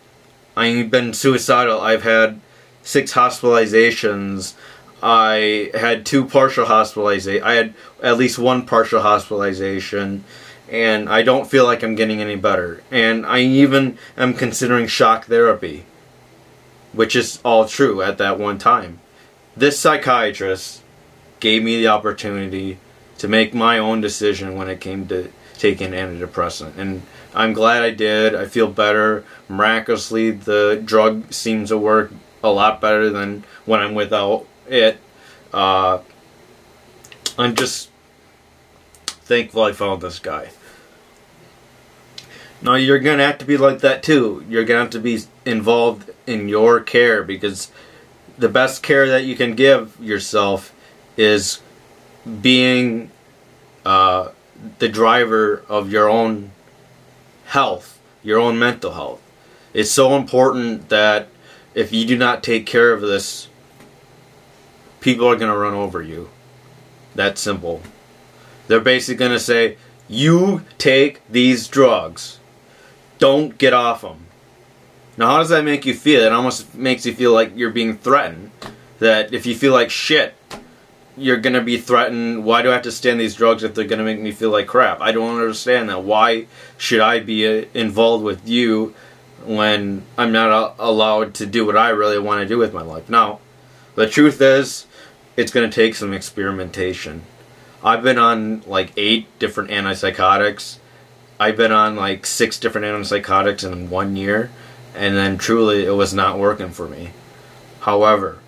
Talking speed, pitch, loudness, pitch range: 150 wpm, 110 Hz, -16 LUFS, 105-125 Hz